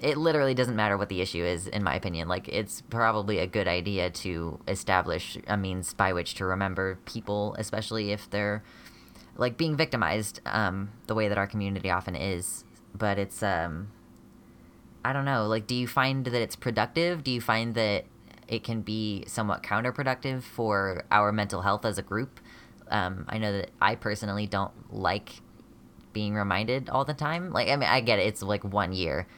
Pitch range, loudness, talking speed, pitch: 95-115 Hz, -29 LUFS, 190 wpm, 105 Hz